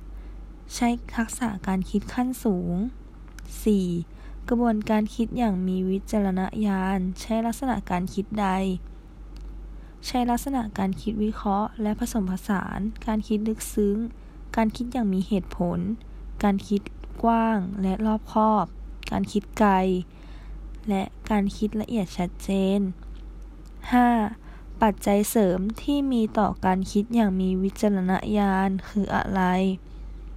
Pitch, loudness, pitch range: 205 Hz, -25 LUFS, 190-225 Hz